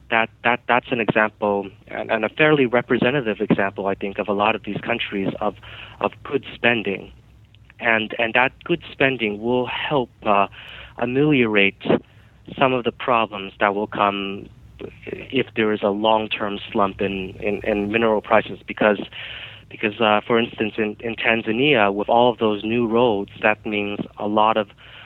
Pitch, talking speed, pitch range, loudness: 110 Hz, 165 wpm, 105-120 Hz, -20 LUFS